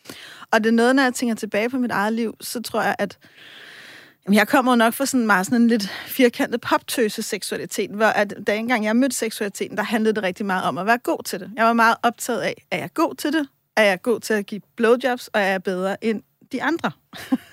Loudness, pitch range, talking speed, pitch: -21 LUFS, 210-245 Hz, 245 wpm, 225 Hz